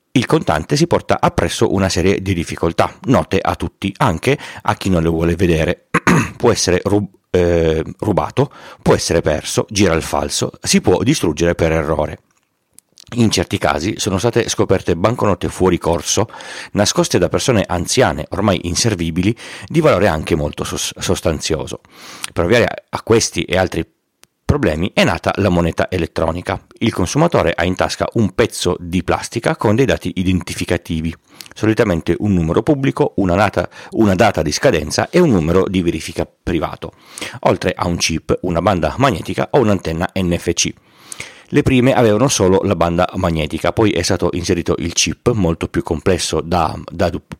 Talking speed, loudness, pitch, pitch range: 160 wpm, -16 LUFS, 90 Hz, 85-100 Hz